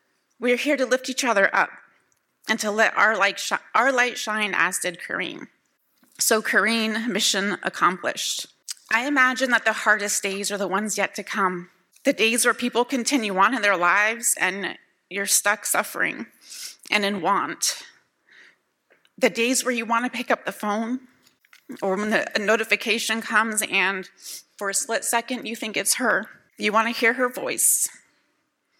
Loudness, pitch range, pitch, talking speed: -22 LUFS, 200-245 Hz, 220 Hz, 175 wpm